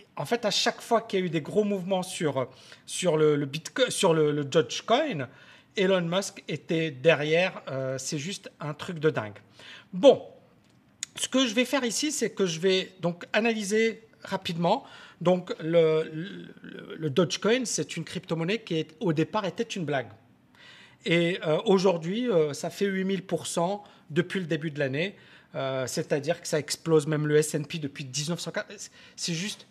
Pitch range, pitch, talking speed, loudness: 155-200 Hz, 170 Hz, 170 wpm, -27 LUFS